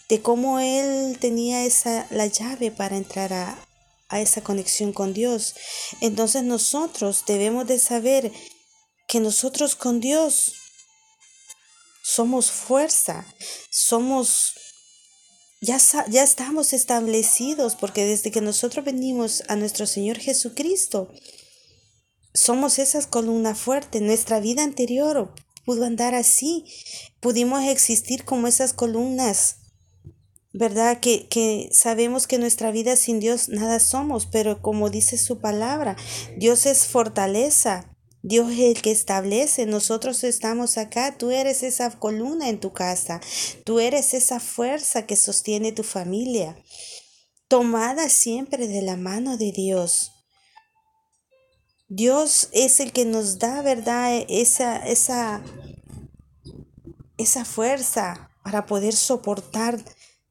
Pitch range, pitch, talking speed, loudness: 215-260 Hz, 235 Hz, 120 wpm, -20 LUFS